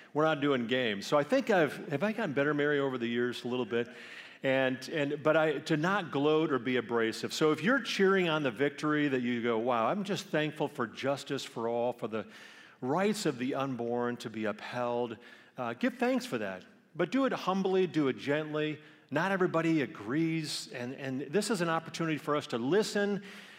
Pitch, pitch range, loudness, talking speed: 150 Hz, 125-180 Hz, -31 LUFS, 205 wpm